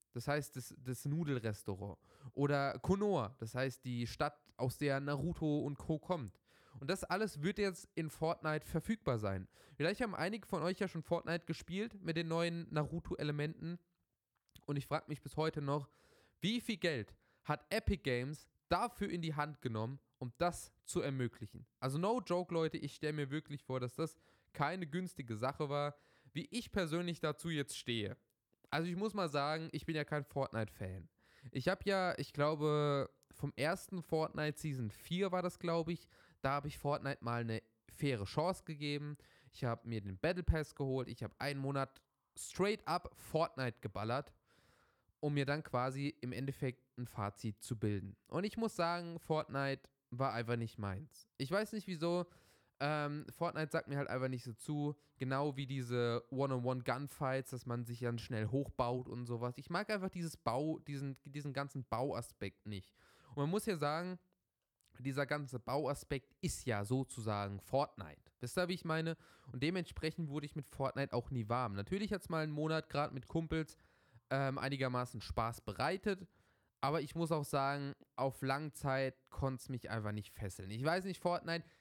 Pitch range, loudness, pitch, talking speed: 125-165 Hz, -40 LUFS, 145 Hz, 175 wpm